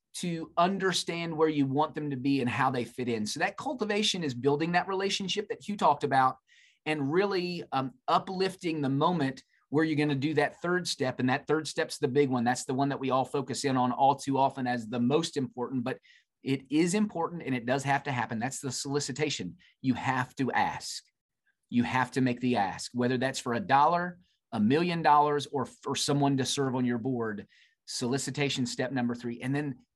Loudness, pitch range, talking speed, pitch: -29 LUFS, 130-160 Hz, 210 wpm, 140 Hz